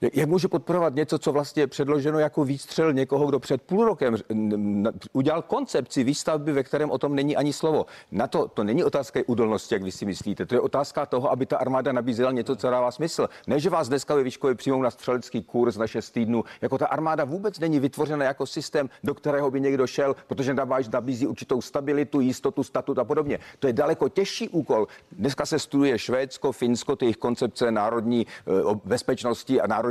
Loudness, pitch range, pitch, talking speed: -25 LUFS, 125-150 Hz, 140 Hz, 195 wpm